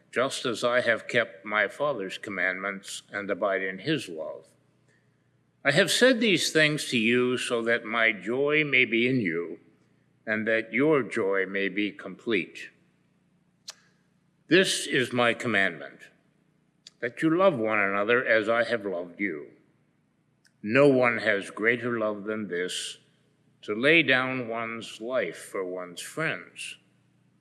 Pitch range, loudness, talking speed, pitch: 100-135 Hz, -25 LUFS, 140 wpm, 115 Hz